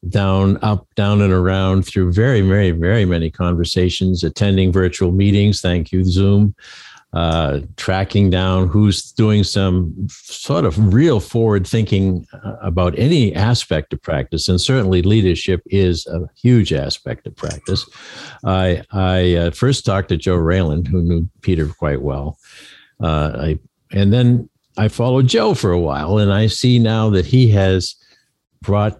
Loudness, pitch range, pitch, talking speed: -16 LUFS, 90-105 Hz, 95 Hz, 150 wpm